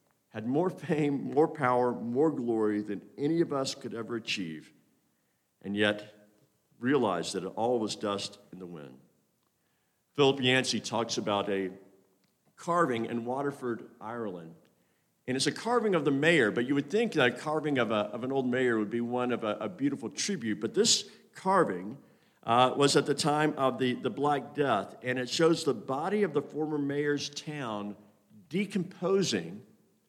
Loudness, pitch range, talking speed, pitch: -30 LUFS, 105-150 Hz, 170 wpm, 130 Hz